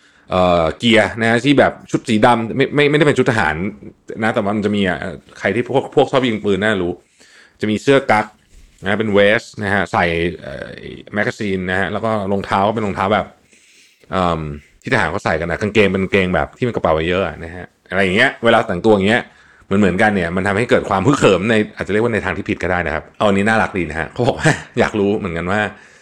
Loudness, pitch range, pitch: -16 LUFS, 90-110 Hz, 100 Hz